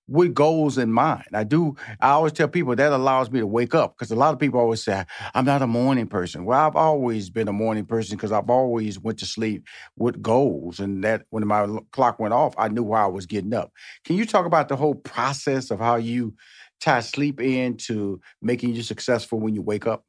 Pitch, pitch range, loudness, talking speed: 120 Hz, 110-135 Hz, -22 LUFS, 235 wpm